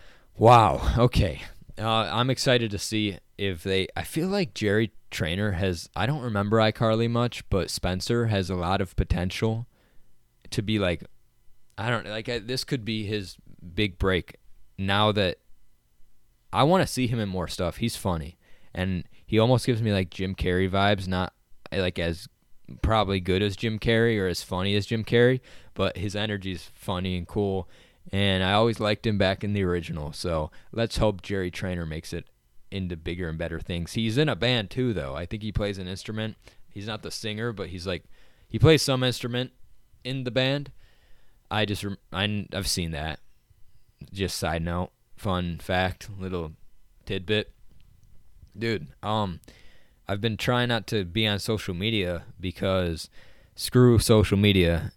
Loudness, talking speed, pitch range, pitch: -26 LUFS, 170 wpm, 90-110 Hz, 100 Hz